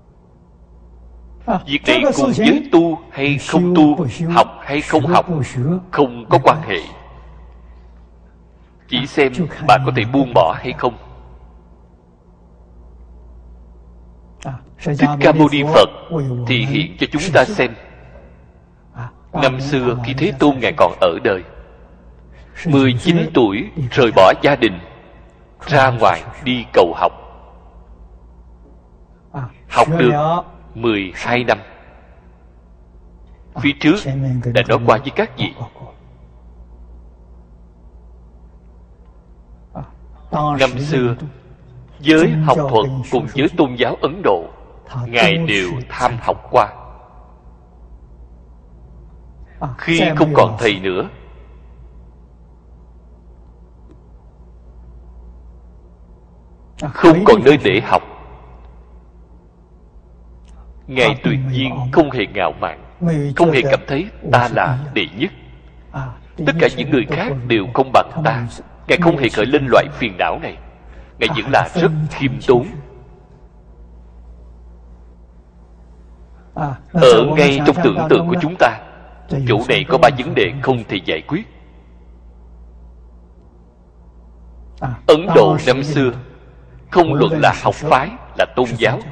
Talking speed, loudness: 110 wpm, -15 LUFS